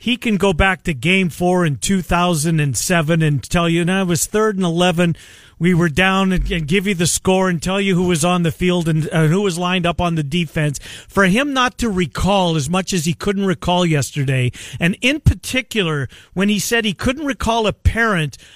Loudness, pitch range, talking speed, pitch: -17 LUFS, 165-195 Hz, 215 wpm, 180 Hz